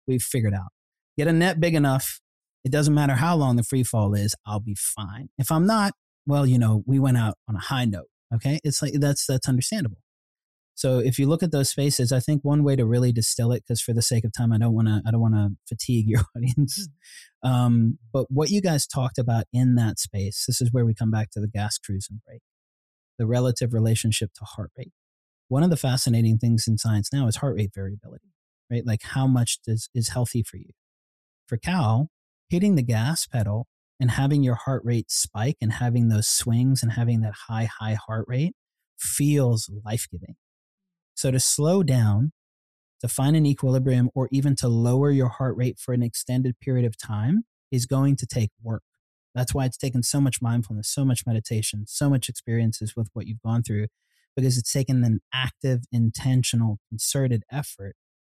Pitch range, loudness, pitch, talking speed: 110-135 Hz, -24 LUFS, 120 Hz, 205 wpm